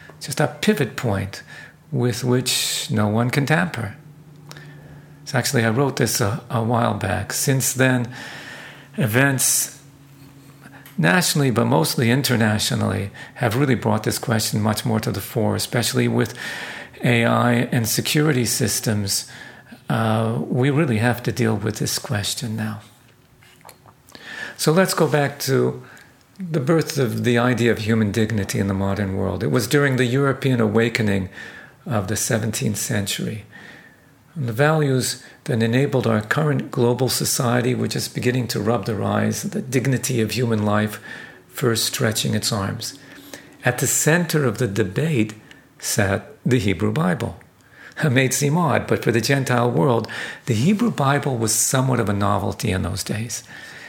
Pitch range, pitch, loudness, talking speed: 110-140 Hz, 120 Hz, -20 LUFS, 150 wpm